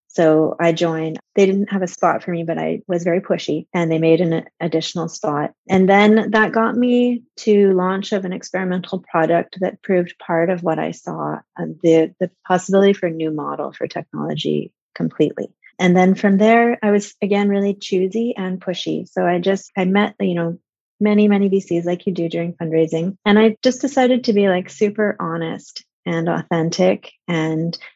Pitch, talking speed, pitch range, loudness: 185 Hz, 190 wpm, 170-205 Hz, -18 LUFS